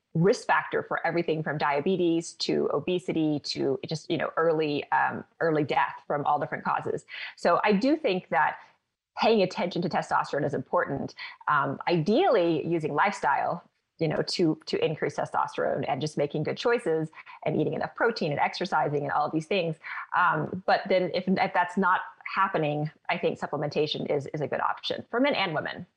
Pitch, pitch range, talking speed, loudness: 170 Hz, 155-195 Hz, 180 wpm, -27 LUFS